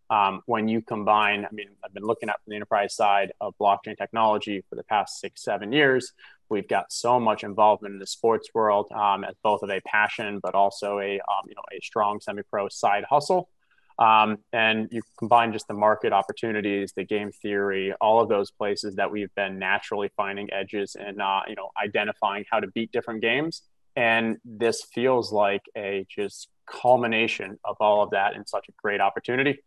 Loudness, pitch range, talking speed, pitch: -25 LUFS, 100-115 Hz, 185 wpm, 105 Hz